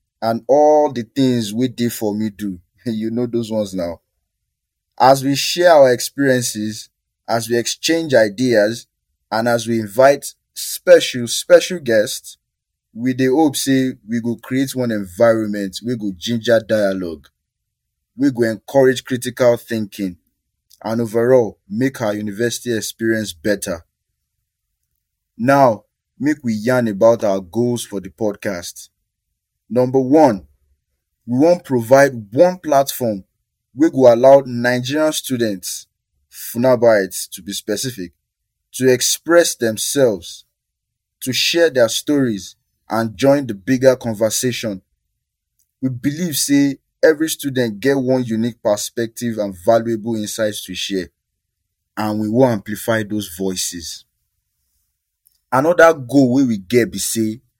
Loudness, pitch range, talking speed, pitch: -17 LUFS, 105-130 Hz, 125 wpm, 115 Hz